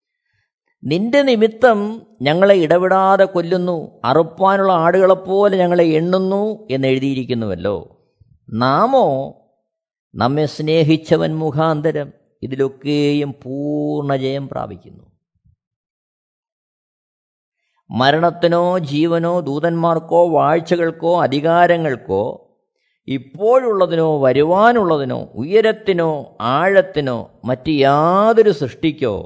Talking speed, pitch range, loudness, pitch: 65 wpm, 145-190 Hz, -16 LUFS, 165 Hz